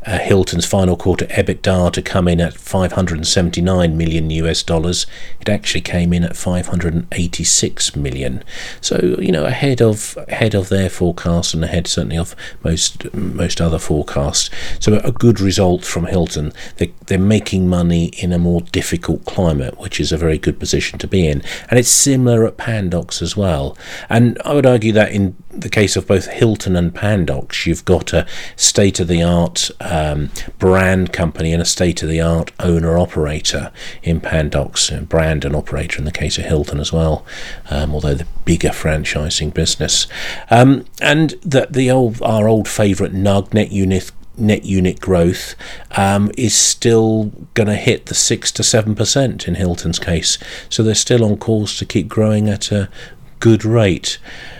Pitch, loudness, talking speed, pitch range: 90 Hz, -16 LUFS, 180 wpm, 85-105 Hz